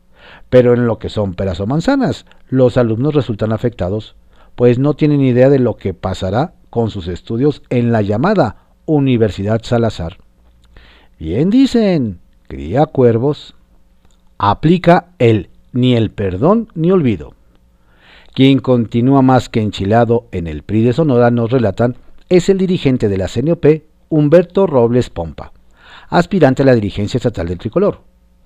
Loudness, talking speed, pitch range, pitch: -14 LUFS, 140 wpm, 95-140 Hz, 120 Hz